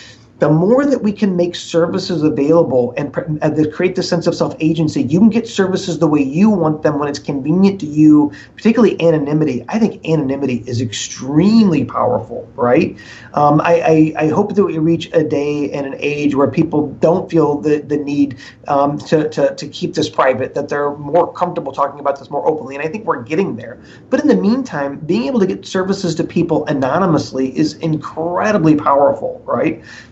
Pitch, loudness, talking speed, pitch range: 155 Hz, -15 LUFS, 195 wpm, 145-175 Hz